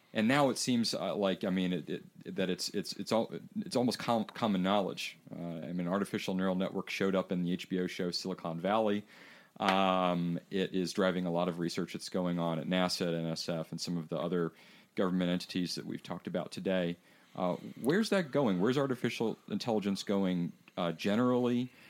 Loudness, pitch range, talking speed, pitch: -33 LUFS, 85-100 Hz, 195 wpm, 95 Hz